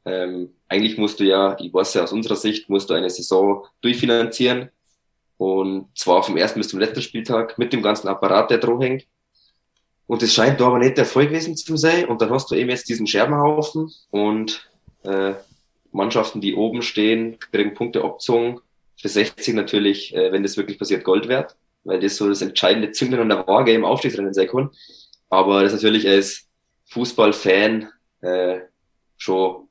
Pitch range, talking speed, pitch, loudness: 95-120 Hz, 180 wpm, 105 Hz, -19 LUFS